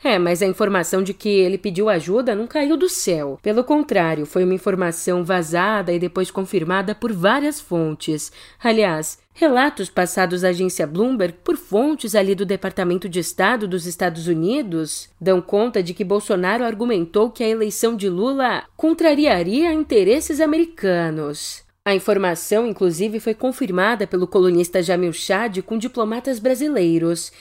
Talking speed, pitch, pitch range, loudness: 145 wpm, 195 Hz, 180-230 Hz, -19 LUFS